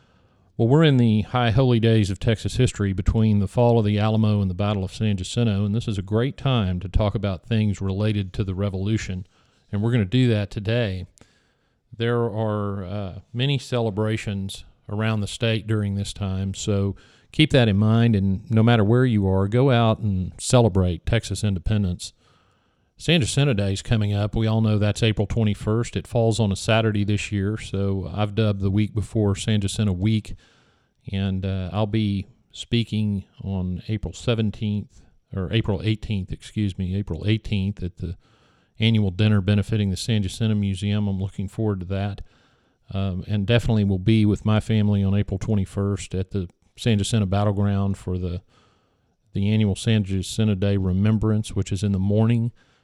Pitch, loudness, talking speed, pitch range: 105 Hz, -23 LUFS, 180 wpm, 100-110 Hz